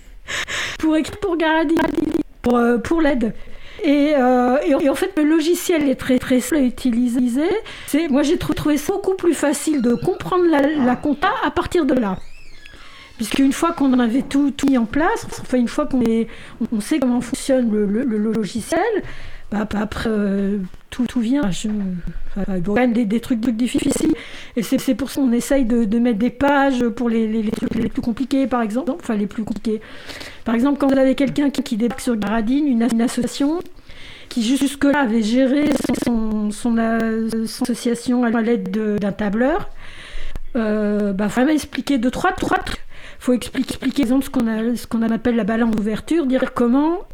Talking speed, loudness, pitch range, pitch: 195 wpm, -19 LUFS, 230-285 Hz, 255 Hz